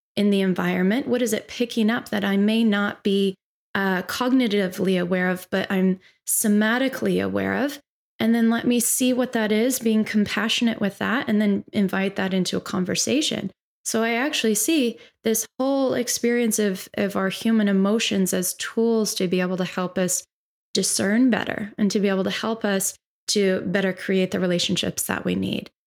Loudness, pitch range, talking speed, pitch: -22 LUFS, 190-230 Hz, 180 wpm, 205 Hz